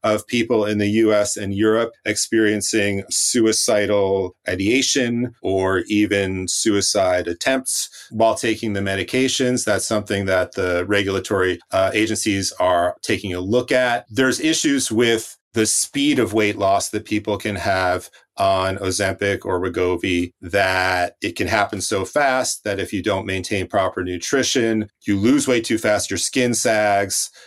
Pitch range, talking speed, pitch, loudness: 95-115 Hz, 145 wpm, 105 Hz, -19 LUFS